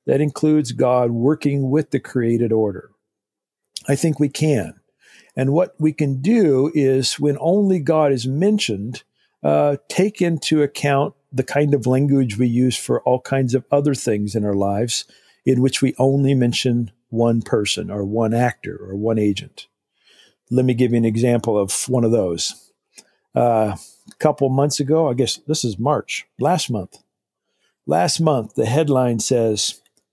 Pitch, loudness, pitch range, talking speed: 130 Hz, -19 LUFS, 115-145 Hz, 165 wpm